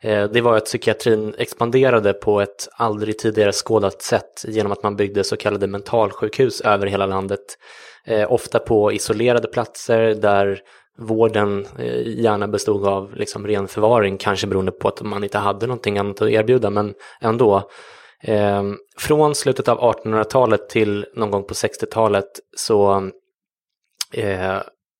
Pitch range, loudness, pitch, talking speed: 100-110 Hz, -19 LUFS, 105 Hz, 135 wpm